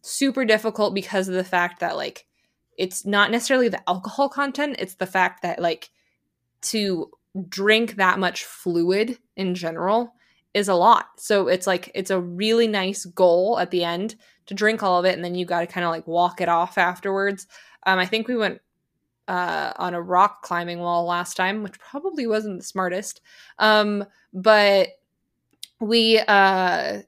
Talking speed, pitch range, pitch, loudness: 175 wpm, 180-215 Hz, 190 Hz, -22 LUFS